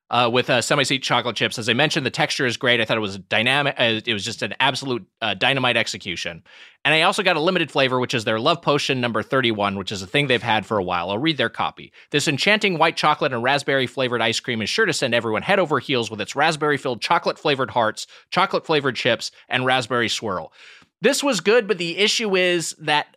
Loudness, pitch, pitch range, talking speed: -20 LUFS, 135 Hz, 120-160 Hz, 240 wpm